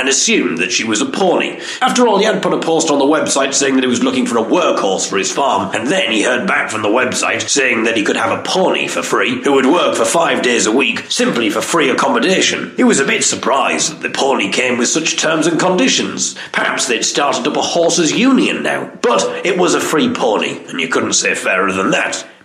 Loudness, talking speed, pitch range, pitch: -14 LUFS, 245 wpm, 135-225 Hz, 165 Hz